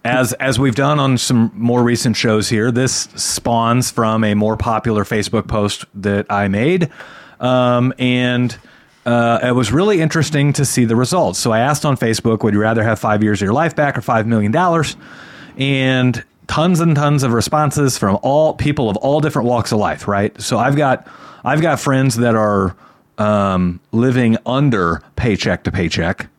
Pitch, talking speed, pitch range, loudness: 120 Hz, 180 wpm, 105-135 Hz, -16 LUFS